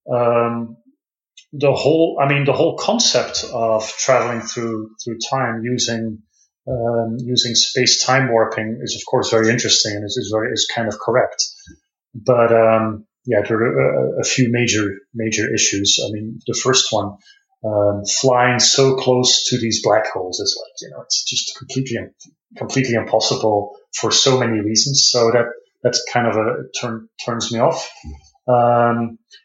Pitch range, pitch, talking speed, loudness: 110-125 Hz, 115 Hz, 165 wpm, -17 LUFS